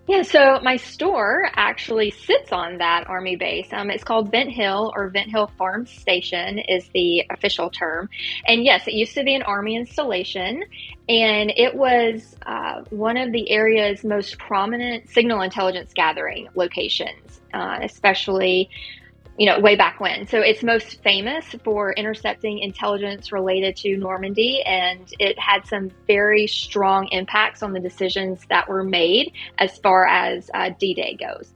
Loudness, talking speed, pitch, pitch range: -20 LUFS, 160 wpm, 205 Hz, 190-225 Hz